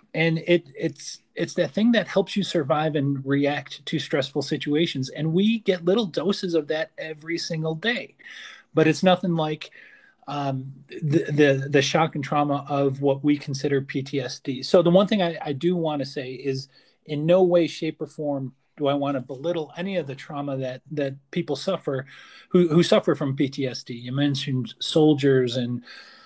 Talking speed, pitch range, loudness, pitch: 185 wpm, 140-175 Hz, -24 LUFS, 155 Hz